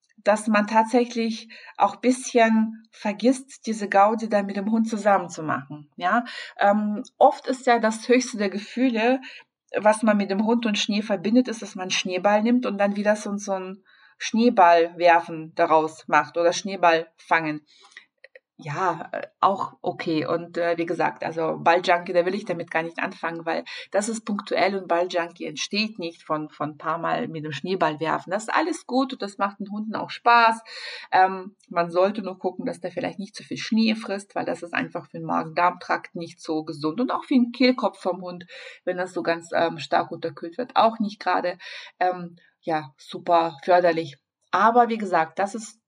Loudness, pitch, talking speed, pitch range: -23 LUFS, 195 Hz, 190 wpm, 170-225 Hz